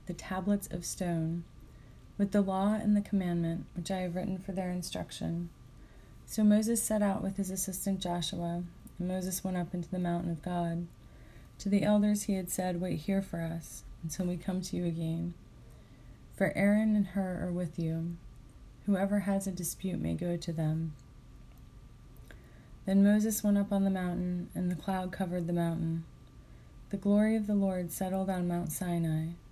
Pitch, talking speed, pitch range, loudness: 180 Hz, 175 wpm, 165-195 Hz, -32 LUFS